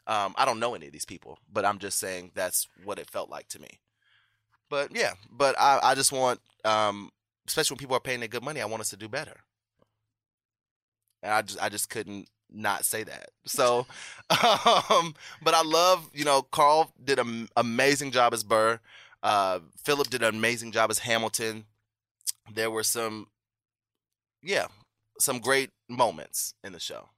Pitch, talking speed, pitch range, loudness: 110 Hz, 180 wpm, 110-130 Hz, -26 LUFS